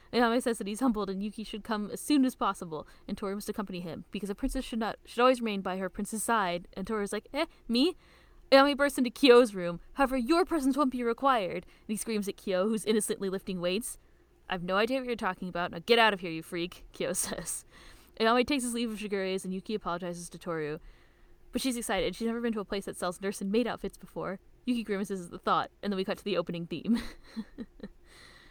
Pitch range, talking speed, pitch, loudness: 190-240 Hz, 240 wpm, 210 Hz, -30 LUFS